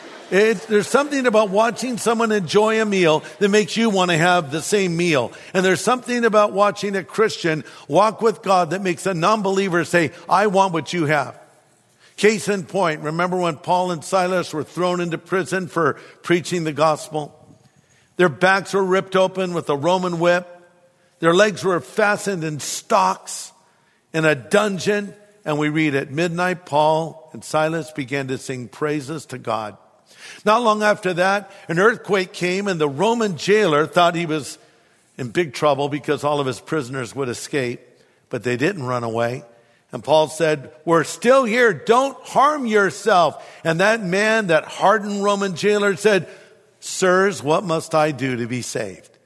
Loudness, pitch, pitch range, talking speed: -19 LUFS, 180 Hz, 155-205 Hz, 170 wpm